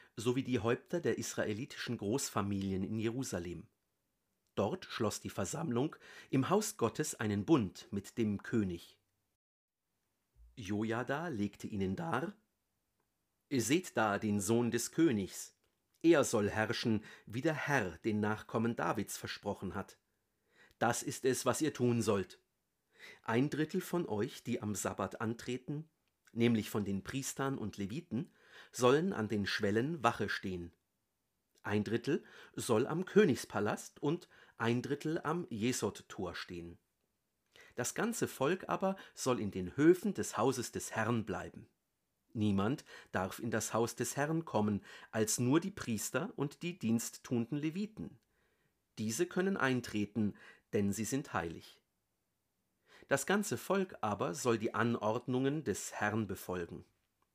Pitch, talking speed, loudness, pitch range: 115 Hz, 130 wpm, -36 LUFS, 105-135 Hz